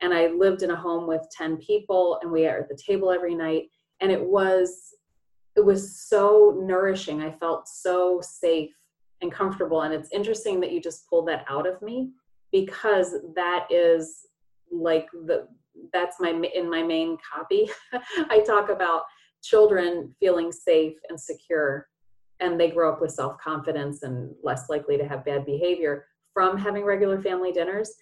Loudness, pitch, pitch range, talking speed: -24 LUFS, 175 Hz, 160-195 Hz, 165 wpm